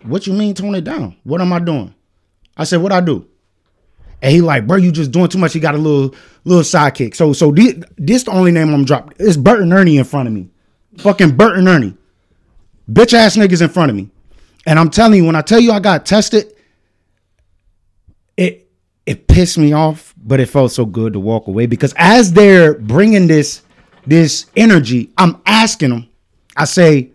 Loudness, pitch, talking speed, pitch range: -11 LUFS, 155 Hz, 205 wpm, 110-185 Hz